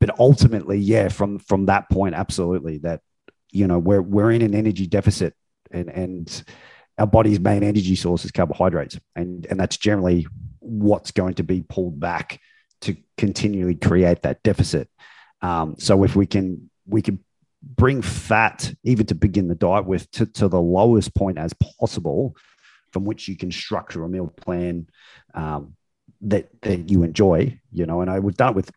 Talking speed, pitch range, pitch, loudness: 175 wpm, 90-105 Hz, 95 Hz, -21 LUFS